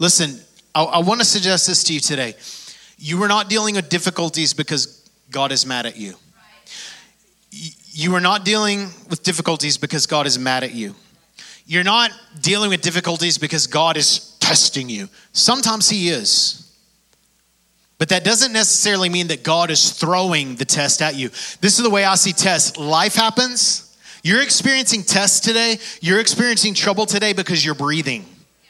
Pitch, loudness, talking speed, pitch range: 180 Hz, -16 LUFS, 170 wpm, 155-210 Hz